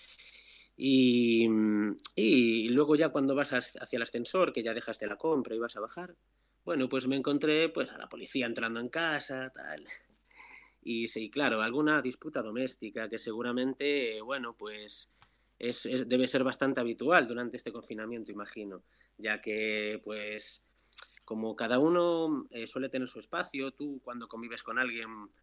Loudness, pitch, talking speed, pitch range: -31 LUFS, 120 Hz, 160 wpm, 110-135 Hz